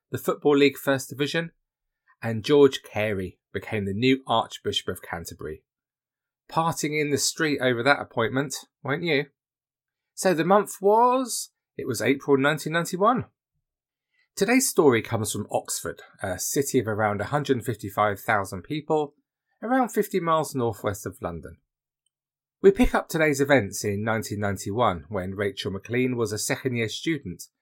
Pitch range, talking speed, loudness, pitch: 110-160 Hz, 155 wpm, -25 LUFS, 135 Hz